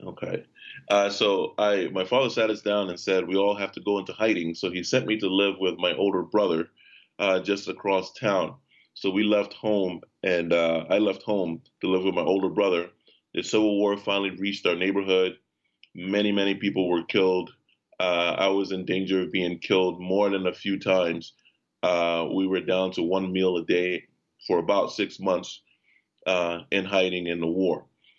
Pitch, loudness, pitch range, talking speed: 95 Hz, -25 LUFS, 90-100 Hz, 195 wpm